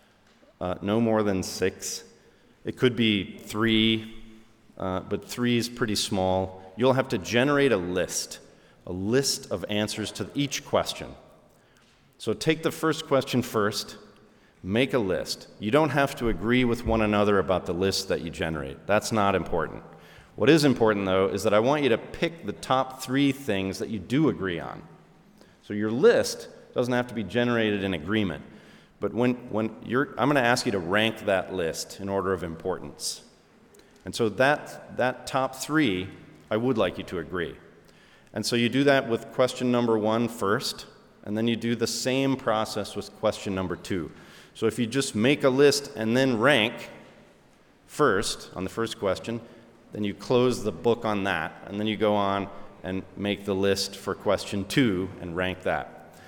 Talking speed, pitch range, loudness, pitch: 180 wpm, 100-125 Hz, -26 LUFS, 110 Hz